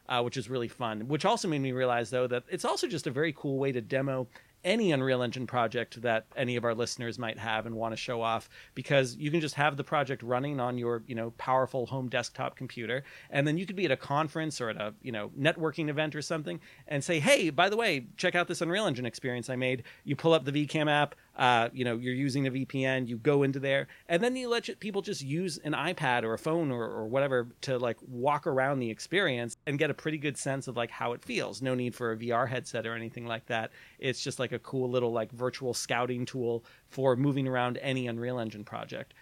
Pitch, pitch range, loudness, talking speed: 130 Hz, 120-150 Hz, -31 LUFS, 245 wpm